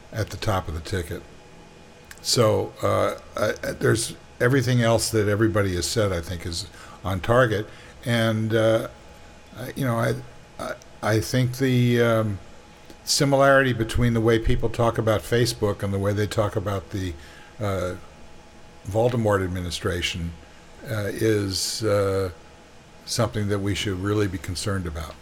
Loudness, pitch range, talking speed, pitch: -23 LUFS, 90-115 Hz, 145 wpm, 105 Hz